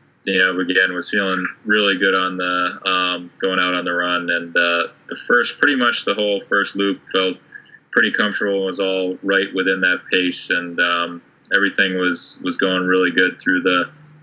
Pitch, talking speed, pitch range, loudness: 95 Hz, 190 wpm, 90-95 Hz, -18 LUFS